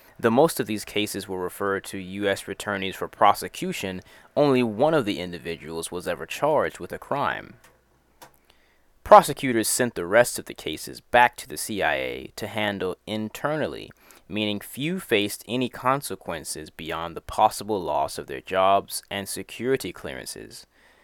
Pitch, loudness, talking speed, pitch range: 100 Hz, -25 LUFS, 150 wpm, 90-115 Hz